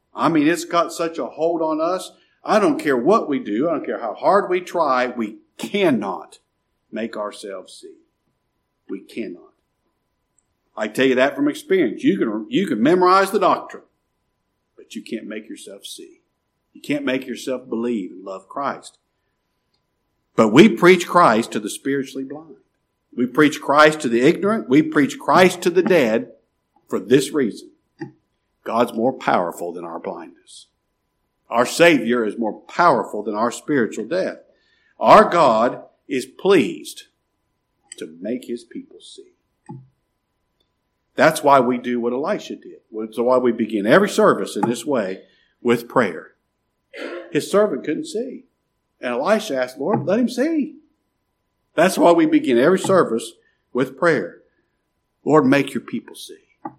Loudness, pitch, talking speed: -18 LUFS, 175 Hz, 155 wpm